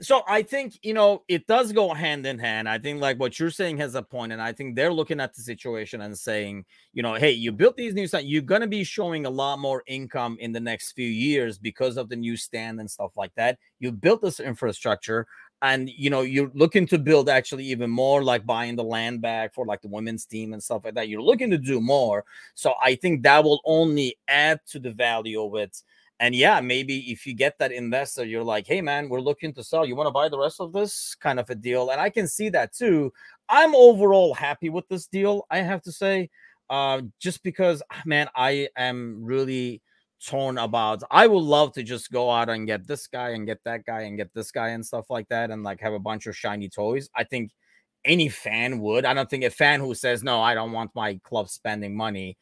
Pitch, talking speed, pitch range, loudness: 130 Hz, 240 wpm, 115-155 Hz, -24 LUFS